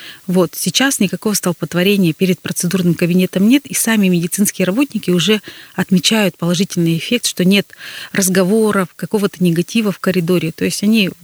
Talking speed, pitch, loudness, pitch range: 140 wpm, 185 Hz, -15 LUFS, 180-205 Hz